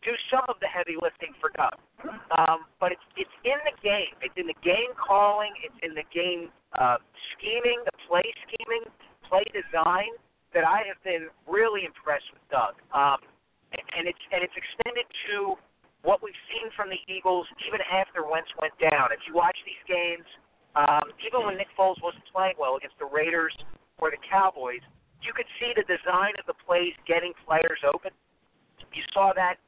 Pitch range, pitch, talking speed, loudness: 165-225 Hz, 185 Hz, 185 wpm, -27 LUFS